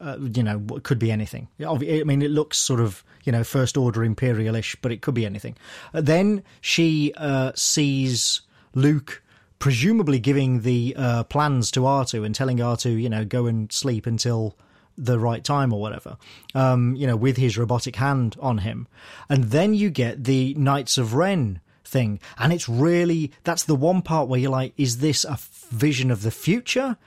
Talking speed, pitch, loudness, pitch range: 185 wpm, 130 Hz, -22 LUFS, 120-145 Hz